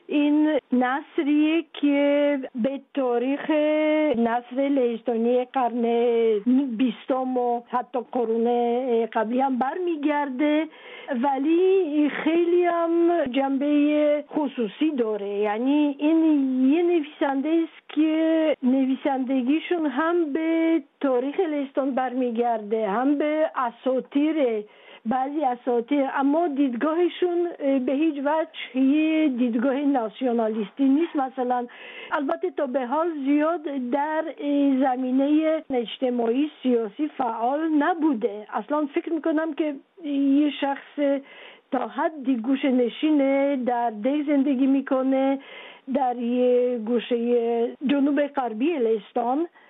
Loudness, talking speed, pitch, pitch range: -23 LUFS, 95 wpm, 275 Hz, 250-305 Hz